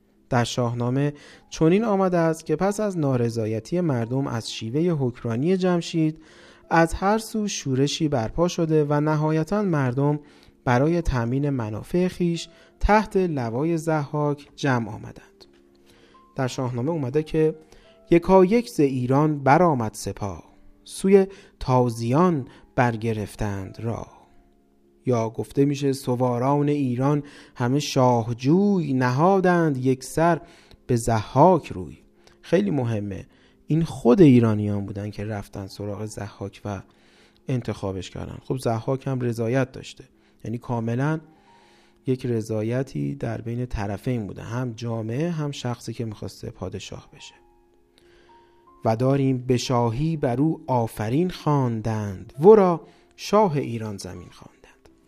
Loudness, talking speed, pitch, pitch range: -23 LUFS, 115 wpm, 125 Hz, 110-155 Hz